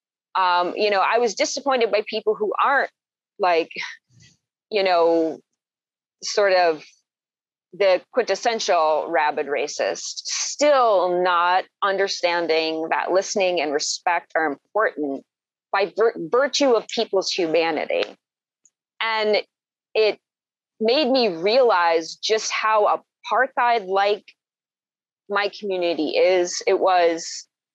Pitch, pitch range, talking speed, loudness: 195 Hz, 170-220 Hz, 105 wpm, -21 LUFS